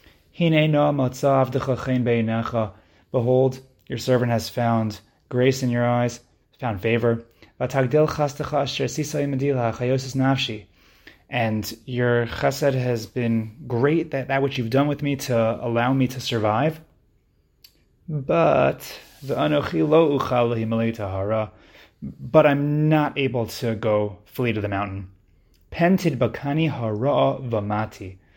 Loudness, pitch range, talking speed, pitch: -22 LUFS, 110-140 Hz, 90 wpm, 120 Hz